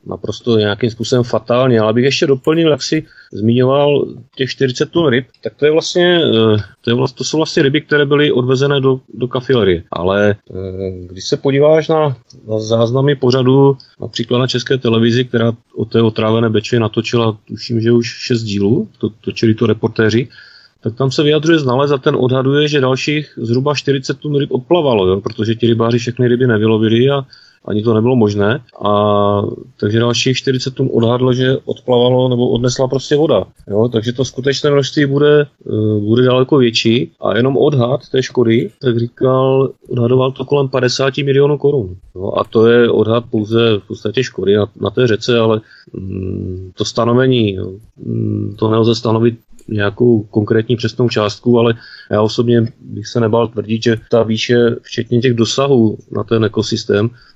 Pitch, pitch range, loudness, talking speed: 120 Hz, 110-130 Hz, -14 LUFS, 170 wpm